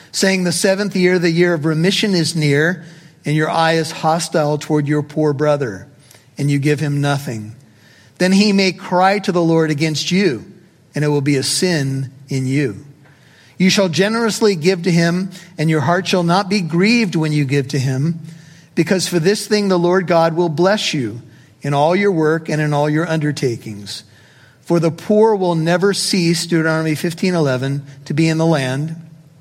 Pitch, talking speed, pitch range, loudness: 160 Hz, 190 wpm, 145-180 Hz, -16 LUFS